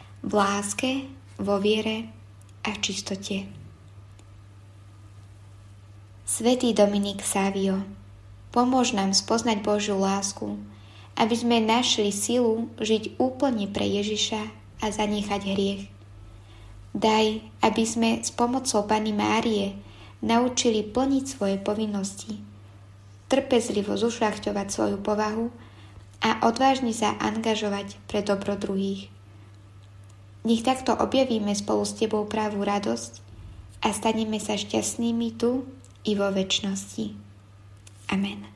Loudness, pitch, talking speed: -25 LUFS, 200 Hz, 100 wpm